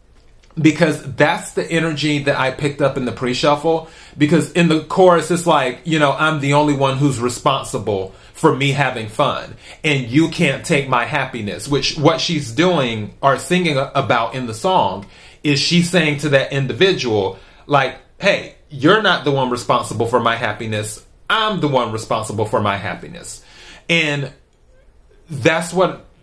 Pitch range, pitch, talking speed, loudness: 130-160 Hz, 145 Hz, 165 wpm, -17 LUFS